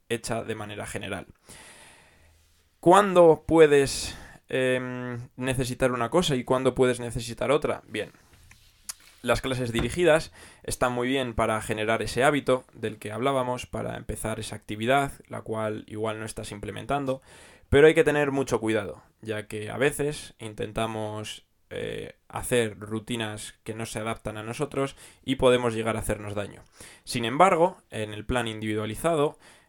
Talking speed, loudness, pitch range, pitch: 145 wpm, -26 LUFS, 105-130 Hz, 115 Hz